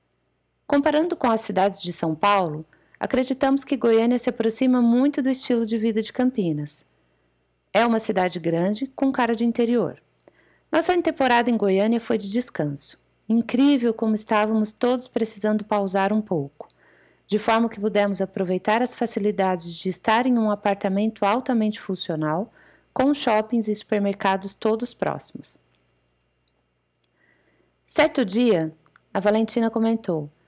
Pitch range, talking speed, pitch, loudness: 190-240 Hz, 130 wpm, 215 Hz, -22 LUFS